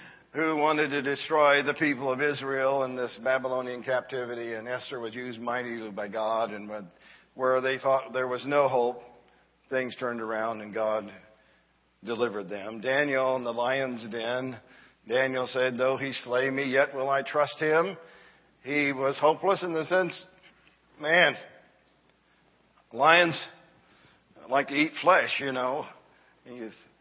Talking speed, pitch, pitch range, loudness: 145 wpm, 130 Hz, 120-140 Hz, -27 LUFS